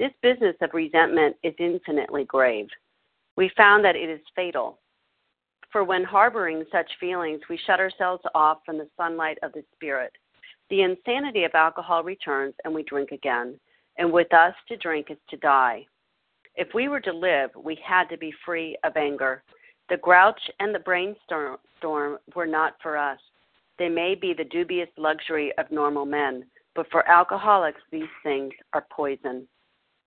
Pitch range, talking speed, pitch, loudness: 150-180 Hz, 165 wpm, 165 Hz, -23 LUFS